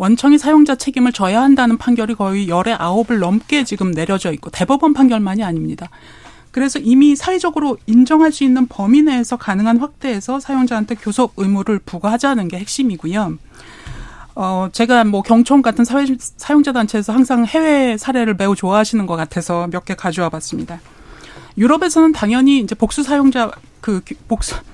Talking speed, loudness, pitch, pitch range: 375 characters per minute, -15 LUFS, 230 Hz, 195-270 Hz